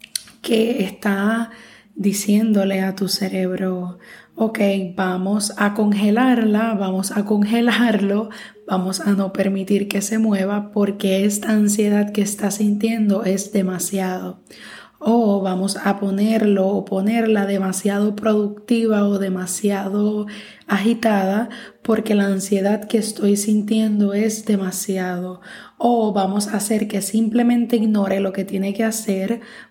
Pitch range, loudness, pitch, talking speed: 195-220 Hz, -19 LUFS, 205 Hz, 120 wpm